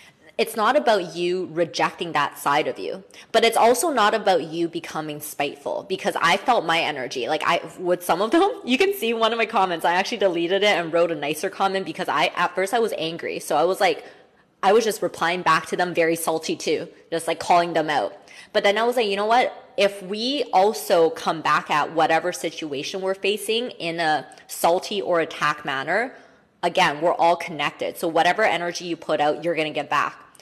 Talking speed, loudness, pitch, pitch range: 215 wpm, -22 LUFS, 180 Hz, 165-220 Hz